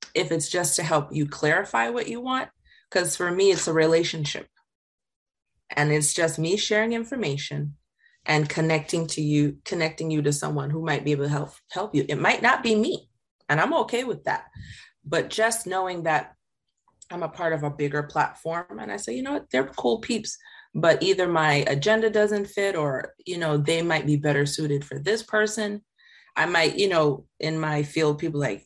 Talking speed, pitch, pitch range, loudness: 195 wpm, 160 Hz, 145-200 Hz, -24 LUFS